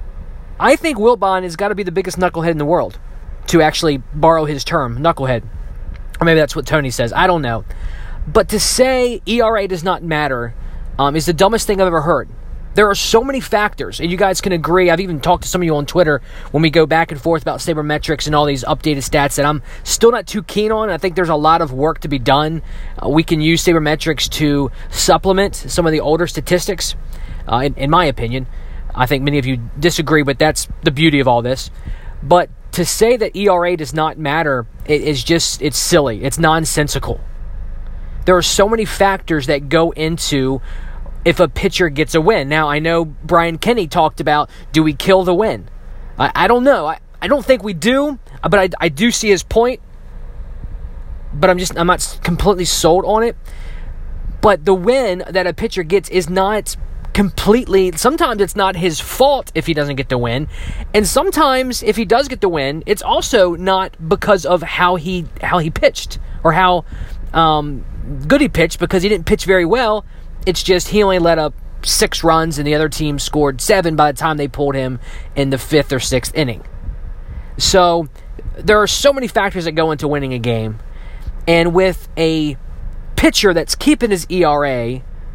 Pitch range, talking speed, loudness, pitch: 140-190 Hz, 200 wpm, -15 LUFS, 165 Hz